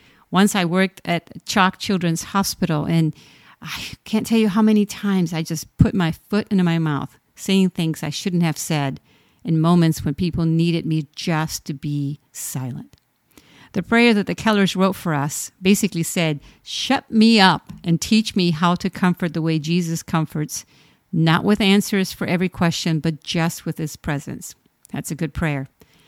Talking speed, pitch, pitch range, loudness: 175 wpm, 170 Hz, 155-195 Hz, -20 LUFS